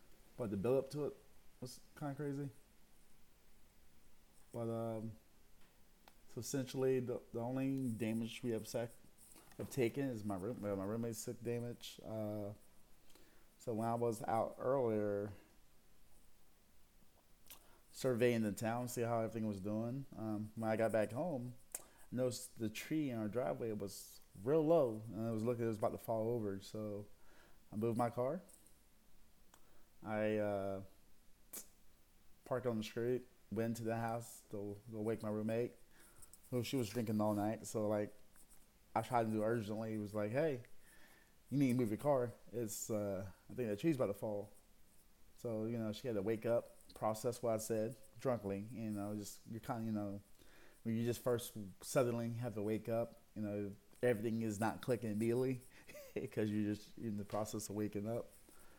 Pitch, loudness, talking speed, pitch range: 110 Hz, -41 LUFS, 175 wpm, 105-120 Hz